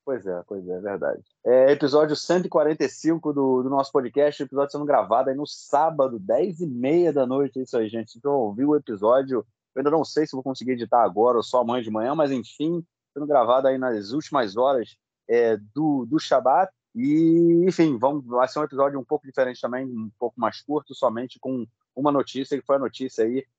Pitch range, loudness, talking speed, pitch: 125-150 Hz, -23 LUFS, 210 wpm, 135 Hz